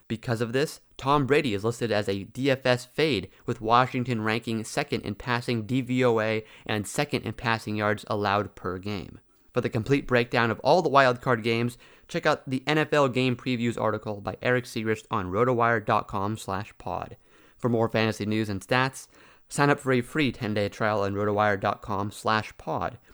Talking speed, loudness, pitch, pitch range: 160 wpm, -26 LUFS, 115 Hz, 105-125 Hz